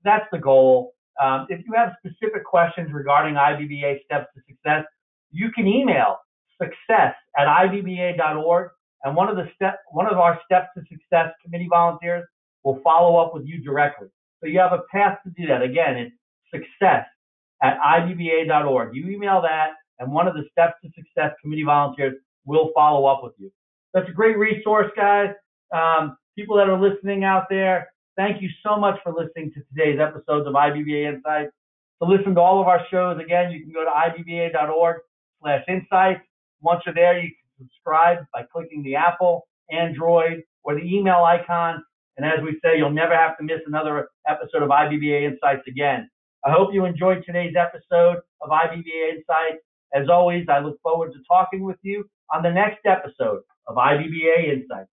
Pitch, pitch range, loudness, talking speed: 170 Hz, 150-185 Hz, -20 LUFS, 180 wpm